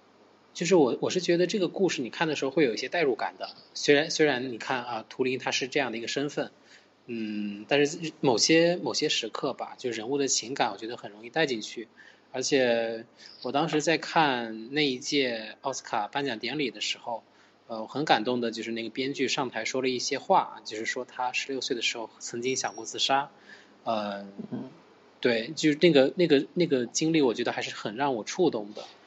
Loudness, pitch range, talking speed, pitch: -27 LUFS, 115-150 Hz, 300 characters per minute, 130 Hz